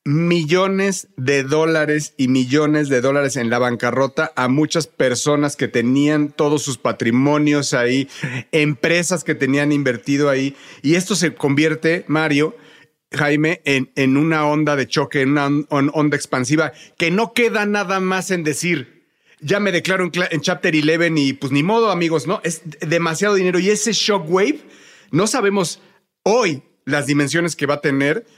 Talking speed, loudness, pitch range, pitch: 160 wpm, -18 LUFS, 140-175 Hz, 150 Hz